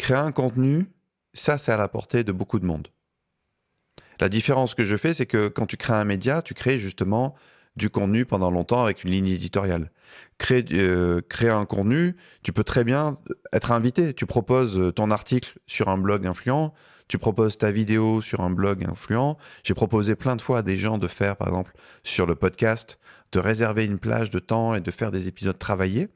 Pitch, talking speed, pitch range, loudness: 110 Hz, 205 wpm, 95-125 Hz, -24 LUFS